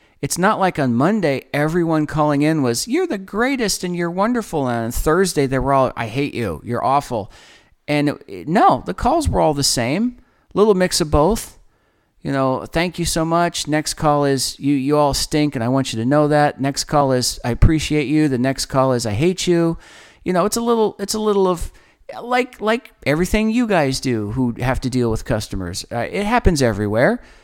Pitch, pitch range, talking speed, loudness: 150 Hz, 130-185 Hz, 210 wpm, -18 LUFS